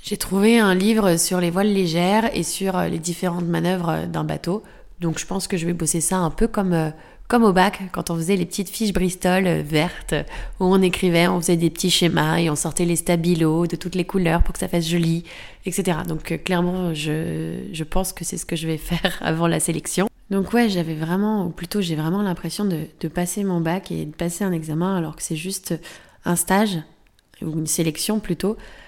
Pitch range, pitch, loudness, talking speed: 165-190 Hz, 175 Hz, -21 LUFS, 215 wpm